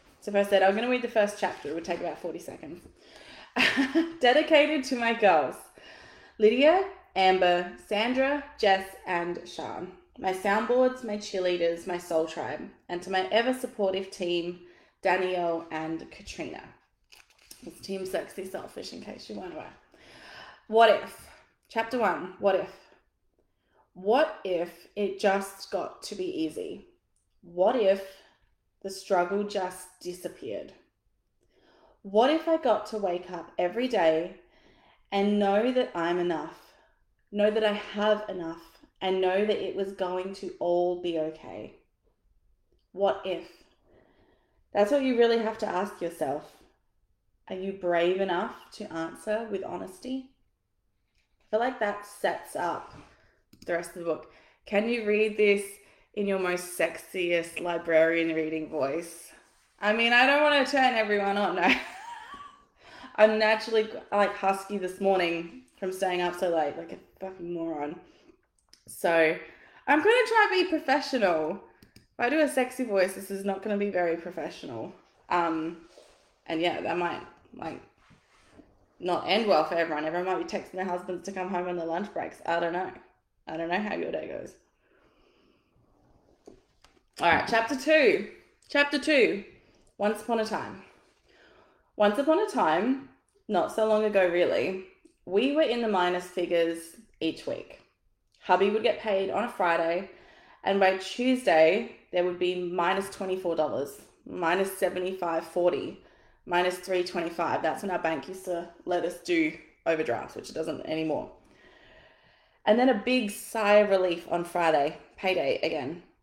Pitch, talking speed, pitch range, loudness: 190 Hz, 150 wpm, 175-220 Hz, -27 LUFS